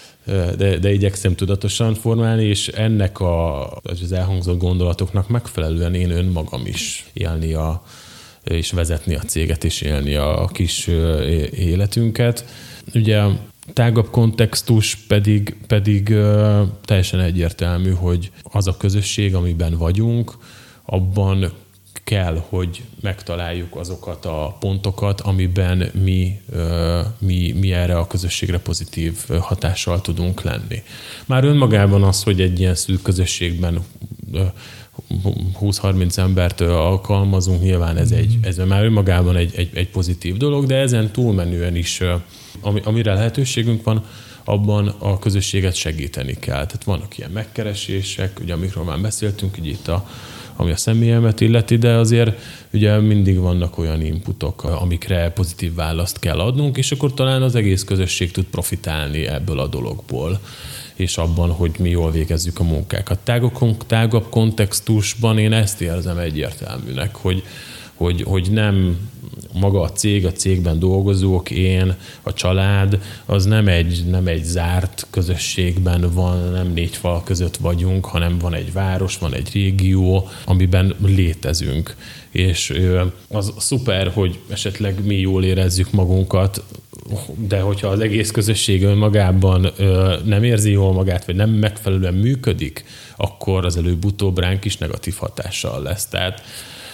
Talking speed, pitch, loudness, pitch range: 130 wpm, 95 Hz, -18 LUFS, 90-105 Hz